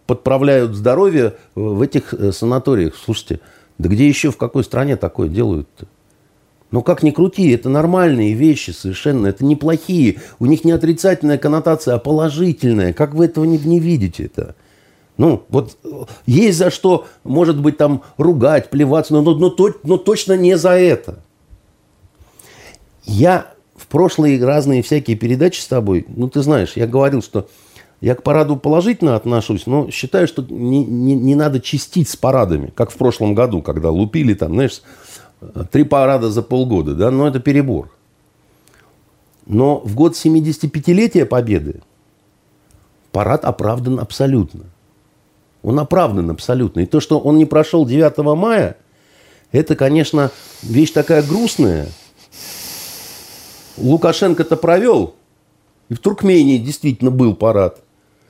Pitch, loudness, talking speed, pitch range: 140 Hz, -15 LUFS, 140 wpm, 120-160 Hz